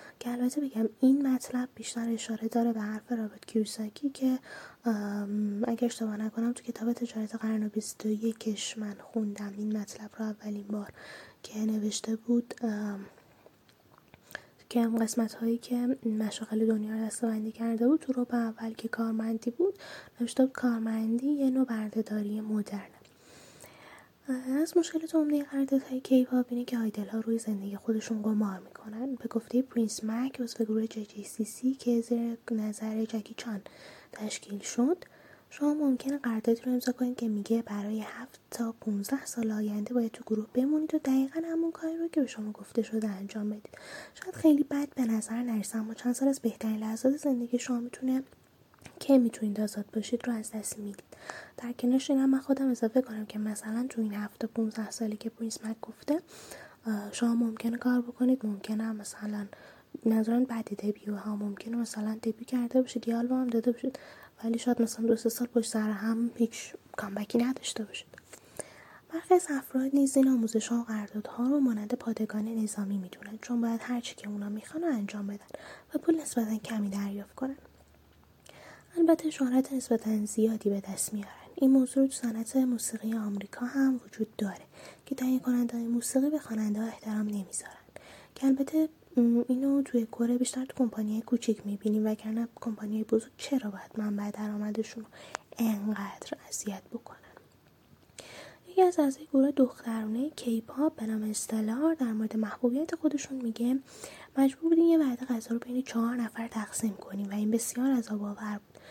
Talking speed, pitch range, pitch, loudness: 165 wpm, 215-255 Hz, 230 Hz, -31 LUFS